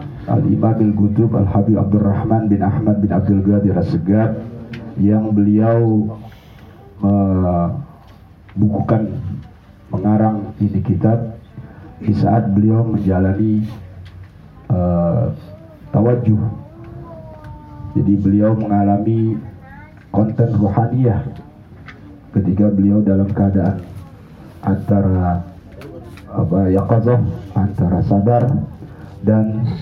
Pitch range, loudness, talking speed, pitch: 100-110 Hz, -16 LUFS, 85 wpm, 105 Hz